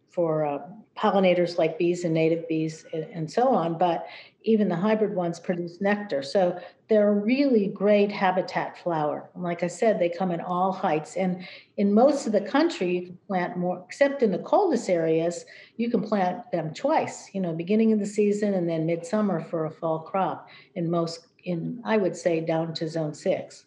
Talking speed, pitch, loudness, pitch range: 195 wpm, 180 Hz, -25 LUFS, 170-210 Hz